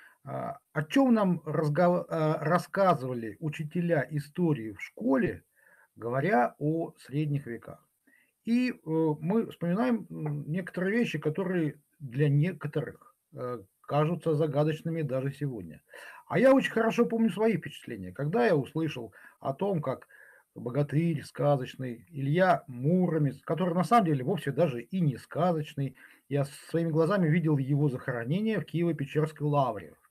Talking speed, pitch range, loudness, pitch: 120 wpm, 140-175 Hz, -29 LUFS, 155 Hz